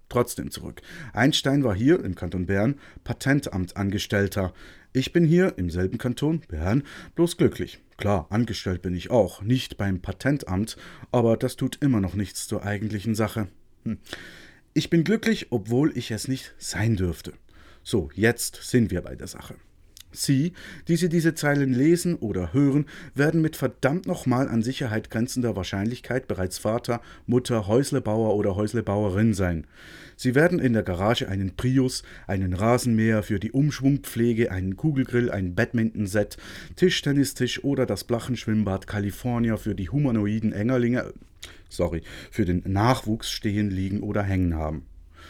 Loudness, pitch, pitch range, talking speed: -25 LUFS, 110 Hz, 95-130 Hz, 145 wpm